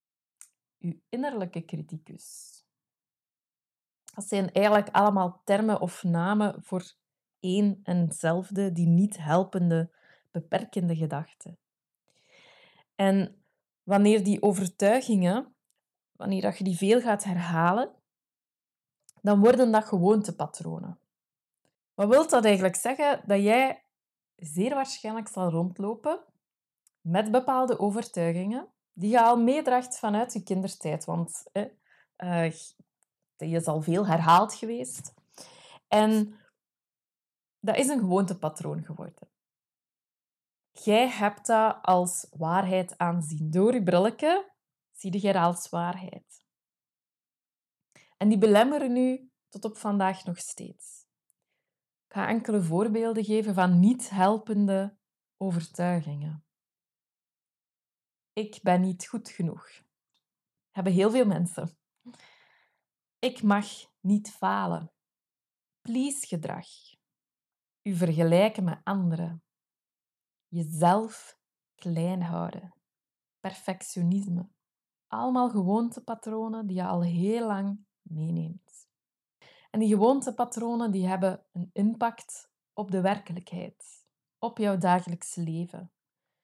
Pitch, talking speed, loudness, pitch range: 195 Hz, 100 wpm, -27 LUFS, 175-220 Hz